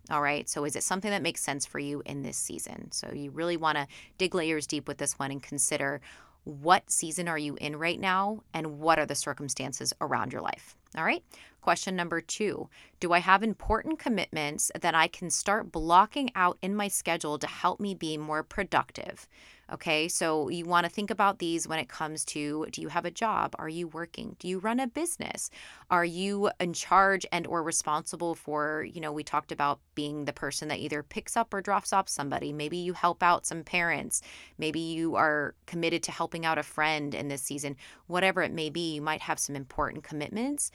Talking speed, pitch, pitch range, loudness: 210 wpm, 165 Hz, 150-185 Hz, -30 LUFS